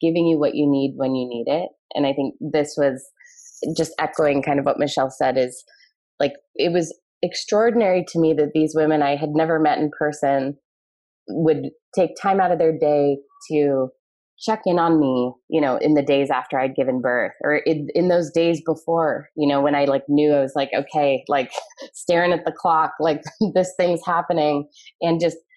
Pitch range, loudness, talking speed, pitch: 140-170 Hz, -21 LUFS, 200 wpm, 155 Hz